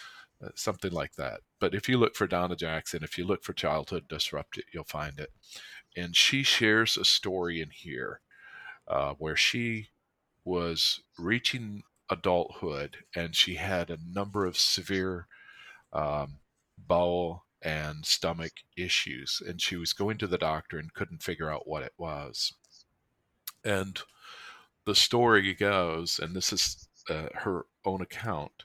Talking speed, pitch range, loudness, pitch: 145 wpm, 80-100 Hz, -29 LUFS, 90 Hz